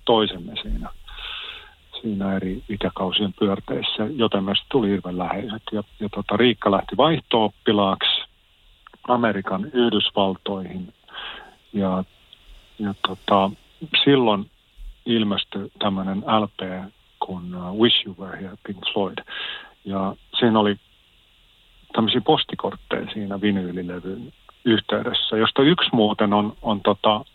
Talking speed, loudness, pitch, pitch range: 105 wpm, -22 LUFS, 100 Hz, 95-110 Hz